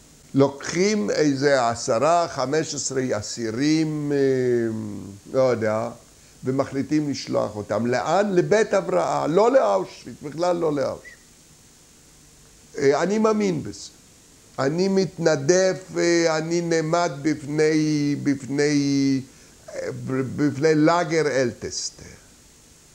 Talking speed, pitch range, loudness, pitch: 90 wpm, 130-170 Hz, -22 LUFS, 145 Hz